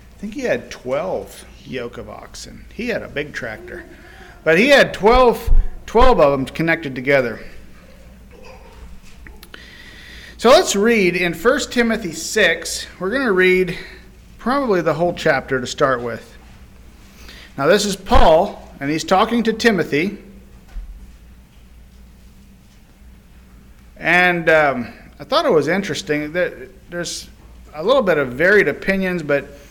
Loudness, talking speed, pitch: -17 LUFS, 130 wpm, 160 Hz